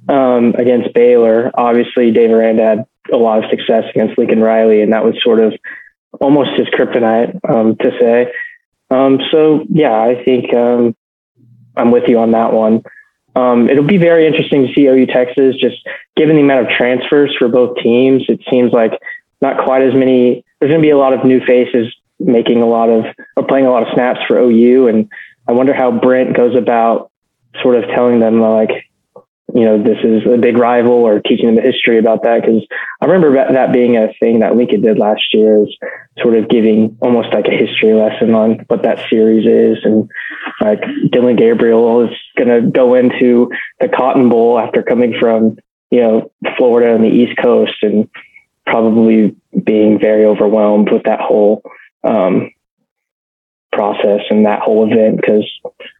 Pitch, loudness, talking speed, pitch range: 120 Hz, -11 LUFS, 180 wpm, 110-130 Hz